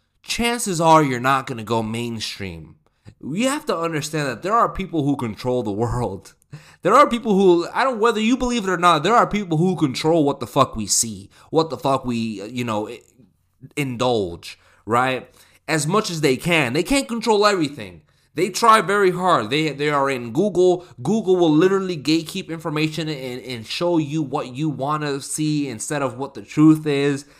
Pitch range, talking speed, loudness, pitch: 125-180 Hz, 195 wpm, -20 LUFS, 155 Hz